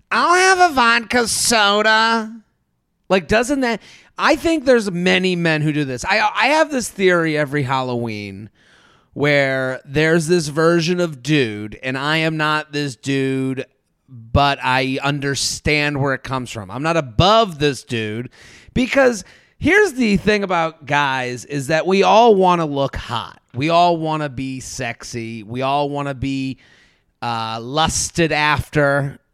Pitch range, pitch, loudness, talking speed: 130-190 Hz, 150 Hz, -17 LUFS, 155 wpm